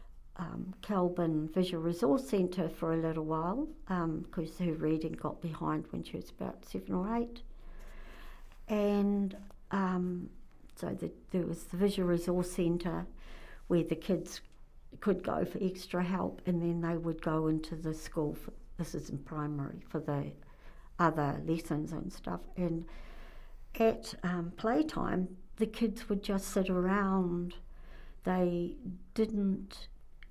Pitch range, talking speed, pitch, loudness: 165-195 Hz, 140 wpm, 175 Hz, -35 LUFS